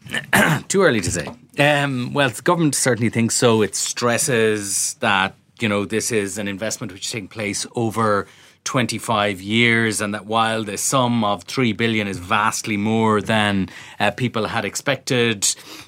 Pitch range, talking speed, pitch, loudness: 105-120 Hz, 165 wpm, 110 Hz, -19 LUFS